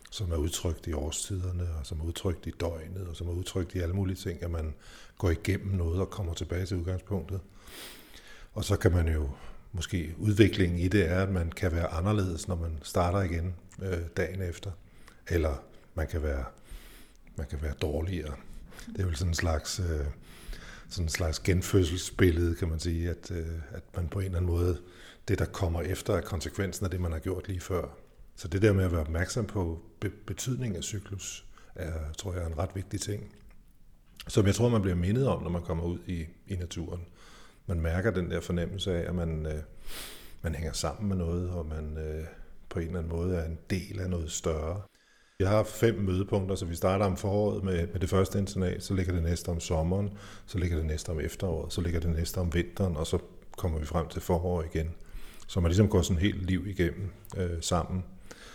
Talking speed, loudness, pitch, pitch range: 210 wpm, -31 LUFS, 90 Hz, 85-95 Hz